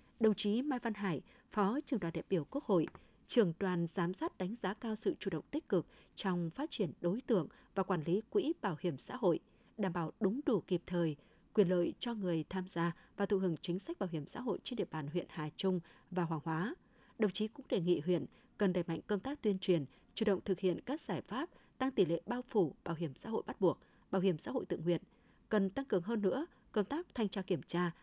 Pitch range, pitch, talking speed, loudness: 175-220 Hz, 190 Hz, 245 wpm, -37 LUFS